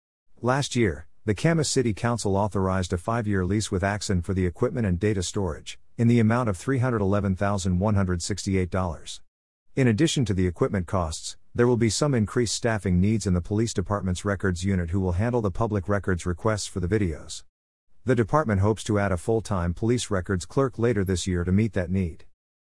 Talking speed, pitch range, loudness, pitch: 185 wpm, 90-115 Hz, -25 LUFS, 100 Hz